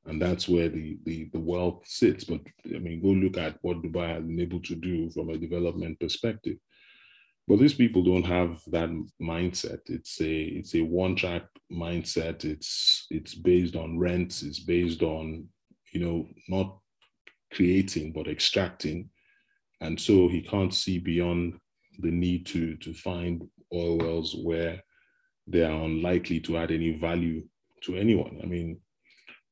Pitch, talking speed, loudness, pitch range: 85 Hz, 155 wpm, -28 LUFS, 80-90 Hz